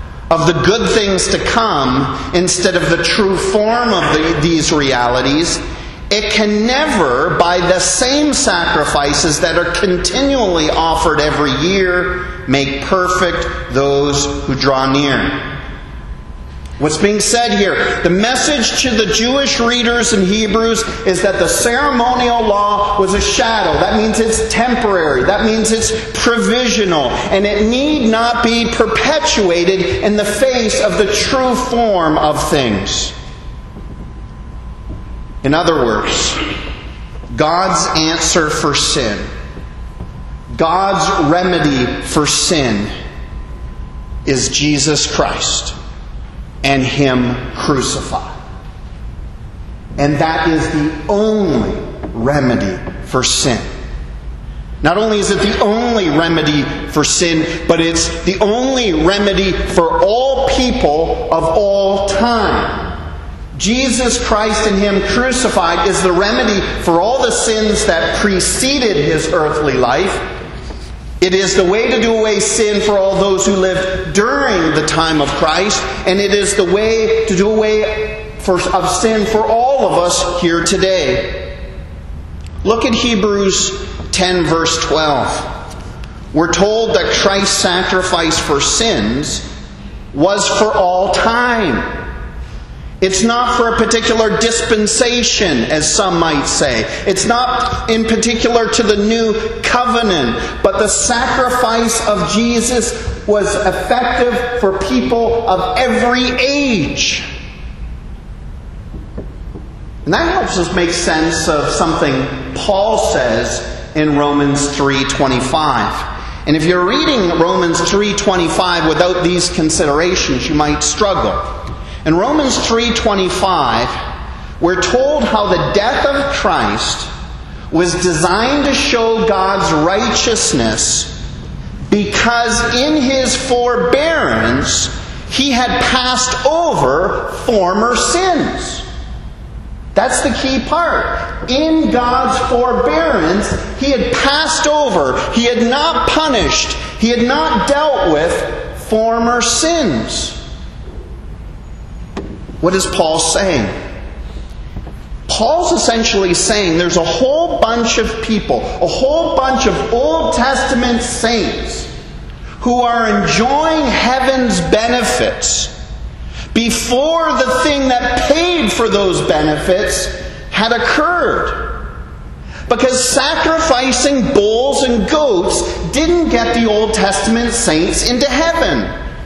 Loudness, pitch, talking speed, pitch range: -13 LUFS, 200 Hz, 115 wpm, 160-240 Hz